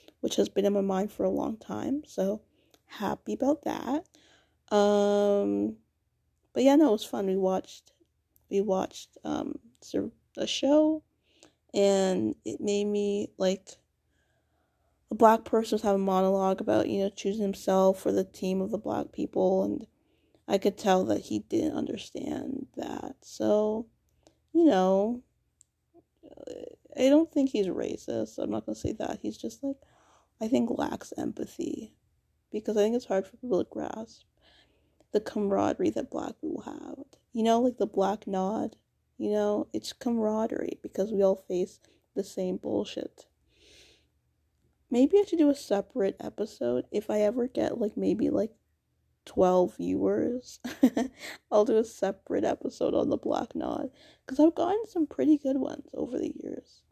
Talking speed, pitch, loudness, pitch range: 160 wpm, 220 Hz, -29 LUFS, 195-285 Hz